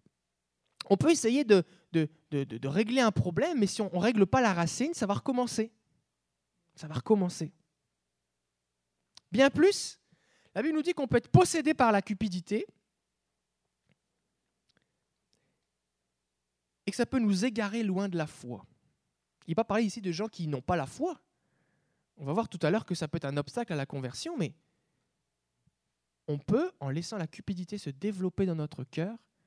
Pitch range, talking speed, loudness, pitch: 140-220 Hz, 175 wpm, -30 LUFS, 180 Hz